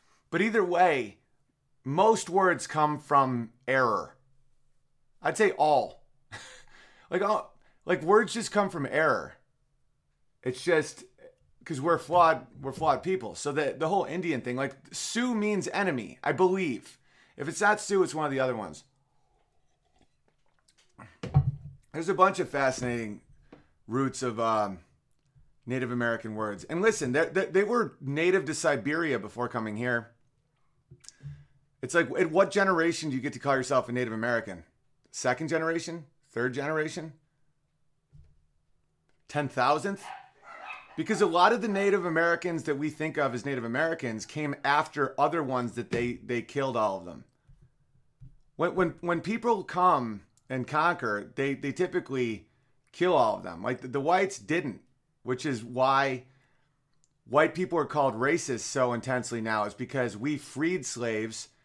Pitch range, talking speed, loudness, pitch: 125-165 Hz, 145 wpm, -28 LUFS, 140 Hz